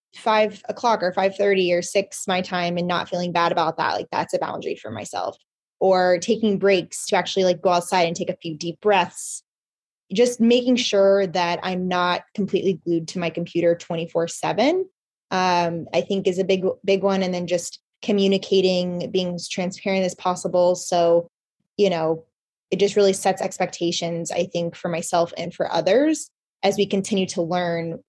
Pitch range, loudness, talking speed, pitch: 175-195 Hz, -22 LUFS, 185 wpm, 185 Hz